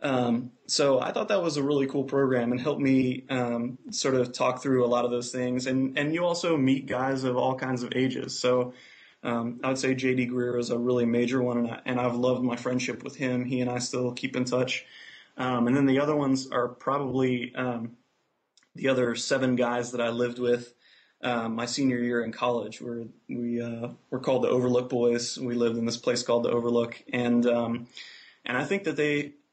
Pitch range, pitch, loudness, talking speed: 120-130 Hz, 125 Hz, -27 LUFS, 220 wpm